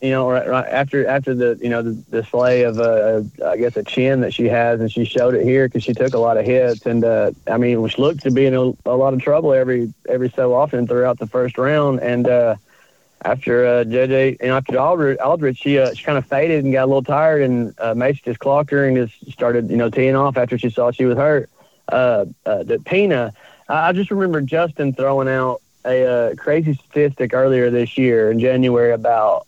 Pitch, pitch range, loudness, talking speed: 125 Hz, 120-135 Hz, -17 LUFS, 235 wpm